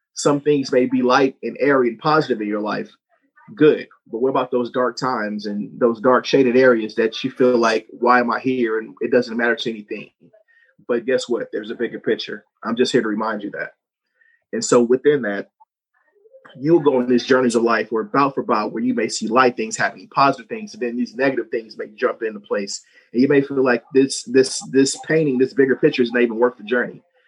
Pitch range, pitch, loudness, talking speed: 120-145 Hz, 130 Hz, -19 LUFS, 225 wpm